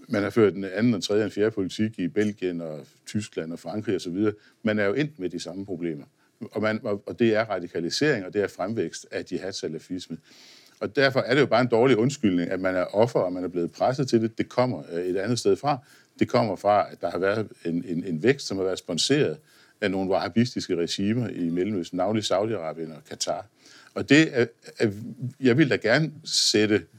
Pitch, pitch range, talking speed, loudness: 105 Hz, 90-115 Hz, 220 wpm, -25 LUFS